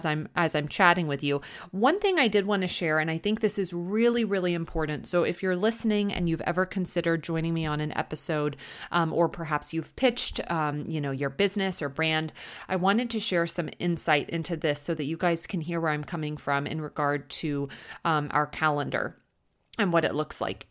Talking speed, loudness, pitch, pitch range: 220 wpm, -27 LUFS, 165 Hz, 150-185 Hz